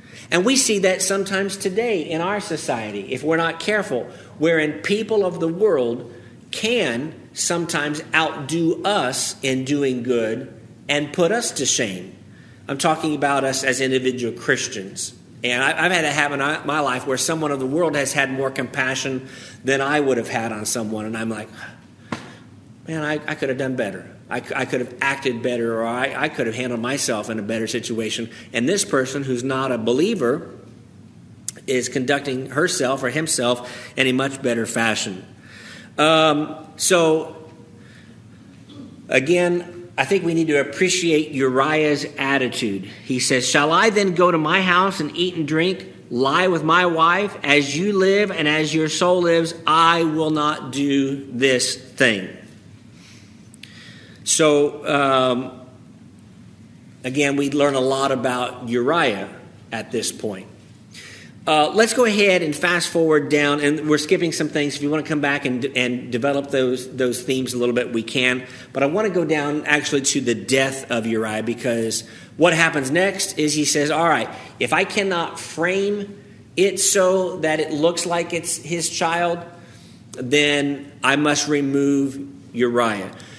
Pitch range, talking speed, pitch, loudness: 125-165 Hz, 165 wpm, 140 Hz, -20 LUFS